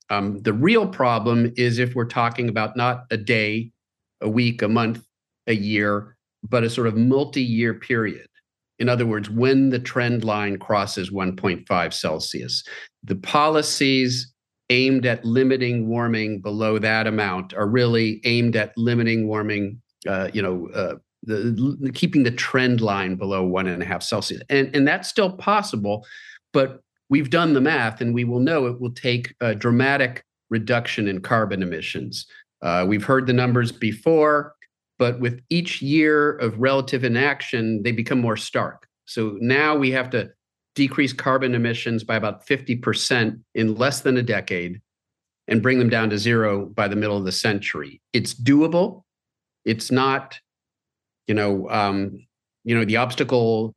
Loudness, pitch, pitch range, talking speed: -21 LUFS, 120 Hz, 110-130 Hz, 160 wpm